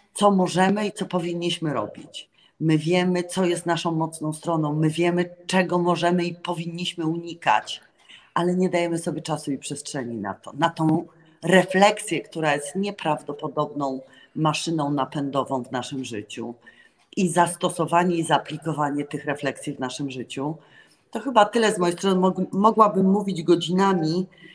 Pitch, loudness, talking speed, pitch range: 170 Hz, -23 LUFS, 140 wpm, 150-180 Hz